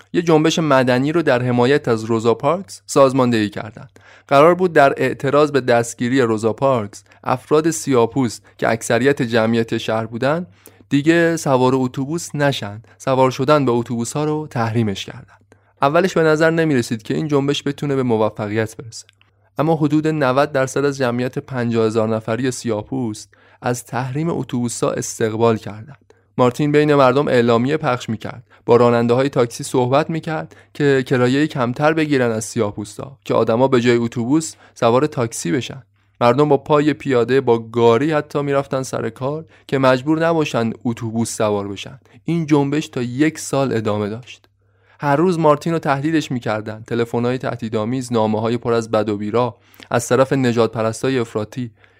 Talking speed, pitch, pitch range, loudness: 155 wpm, 125 Hz, 115-140 Hz, -18 LUFS